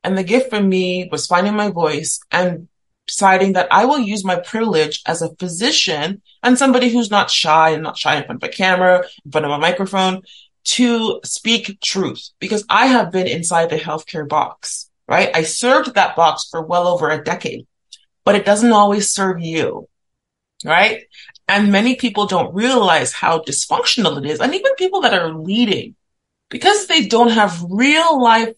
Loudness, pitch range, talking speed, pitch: -15 LUFS, 170-235 Hz, 185 wpm, 195 Hz